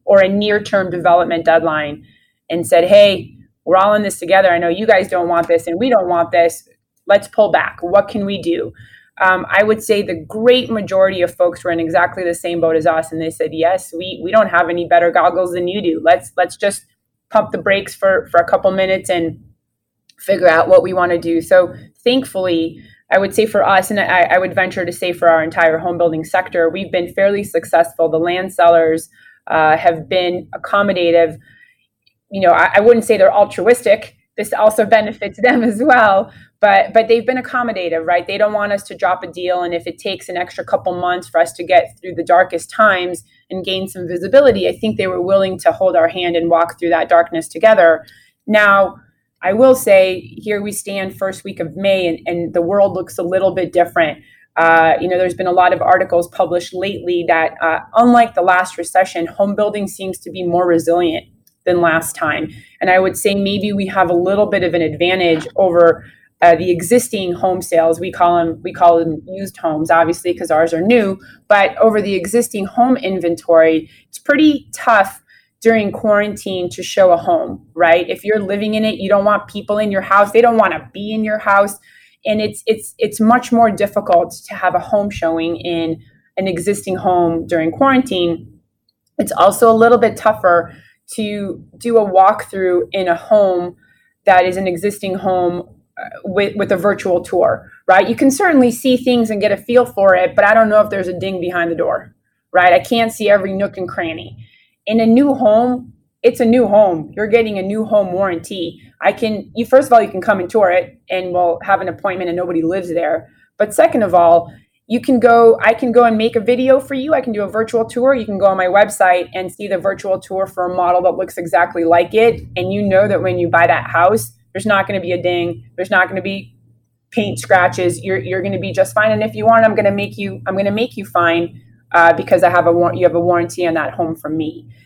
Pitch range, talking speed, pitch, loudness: 170-210 Hz, 220 wpm, 185 Hz, -14 LUFS